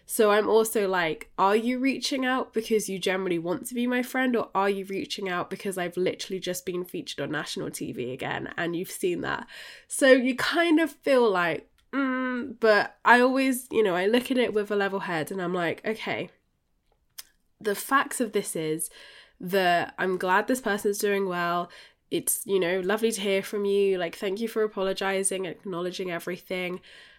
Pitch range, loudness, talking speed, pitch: 185-245 Hz, -26 LUFS, 190 wpm, 200 Hz